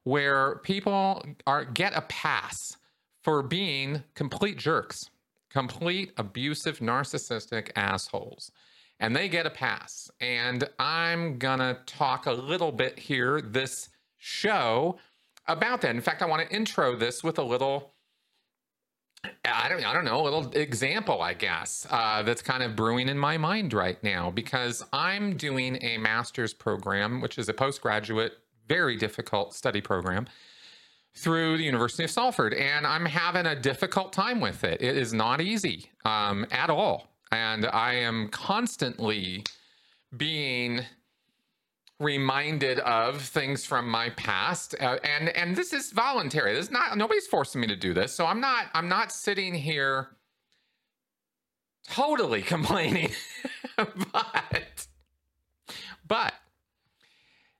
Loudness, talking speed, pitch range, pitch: -28 LUFS, 135 wpm, 115-165 Hz, 135 Hz